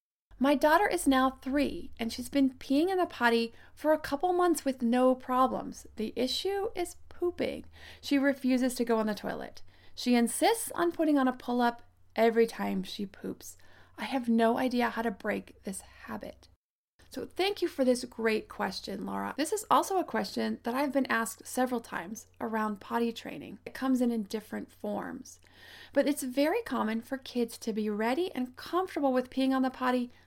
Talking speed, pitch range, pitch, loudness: 190 wpm, 230-280 Hz, 255 Hz, -30 LUFS